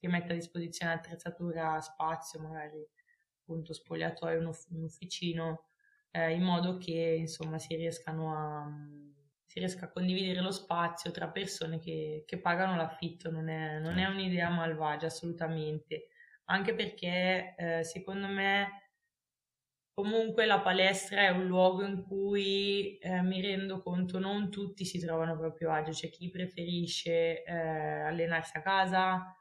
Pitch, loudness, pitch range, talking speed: 170 Hz, -34 LUFS, 160-190 Hz, 145 wpm